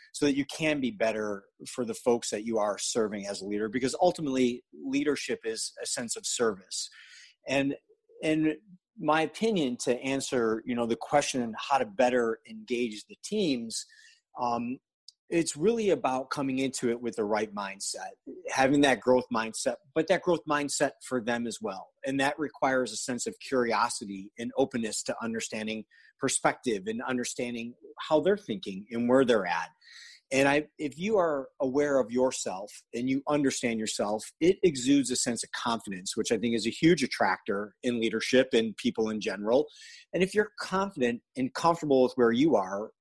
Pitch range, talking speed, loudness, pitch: 120-160 Hz, 175 wpm, -29 LUFS, 135 Hz